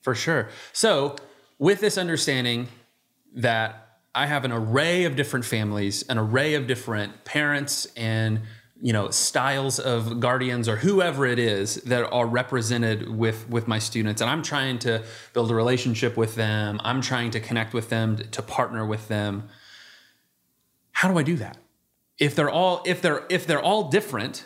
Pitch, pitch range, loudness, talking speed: 120 Hz, 110-145 Hz, -24 LUFS, 170 wpm